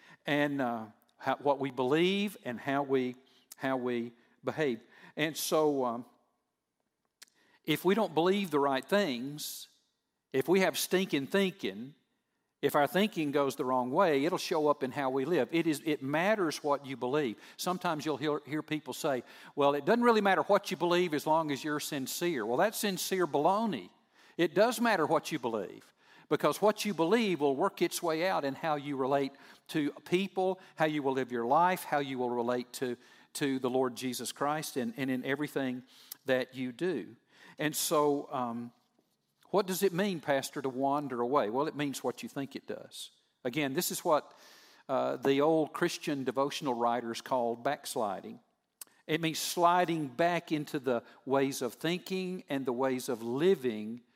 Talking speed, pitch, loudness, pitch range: 175 wpm, 145 Hz, -32 LUFS, 130-175 Hz